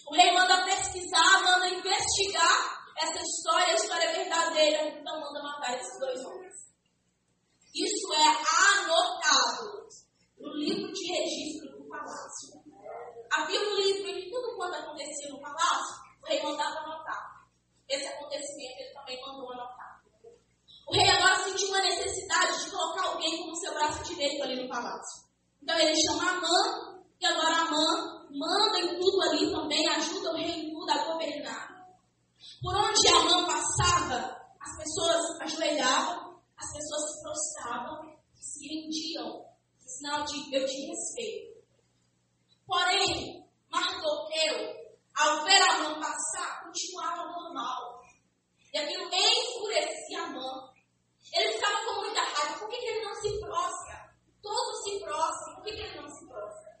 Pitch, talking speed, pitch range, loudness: 330 Hz, 145 wpm, 300-370 Hz, -28 LUFS